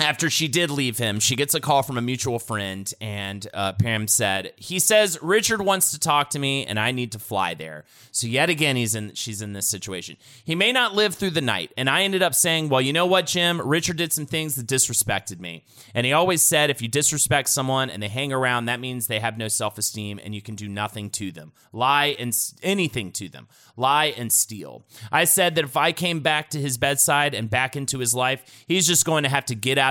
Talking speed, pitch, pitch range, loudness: 245 wpm, 130 Hz, 110-155 Hz, -21 LUFS